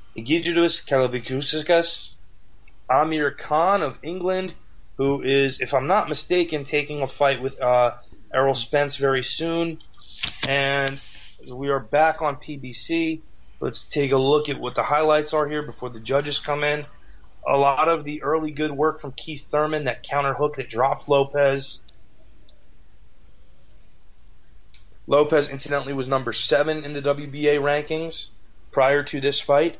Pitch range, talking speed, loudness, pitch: 135-155 Hz, 145 wpm, -22 LUFS, 145 Hz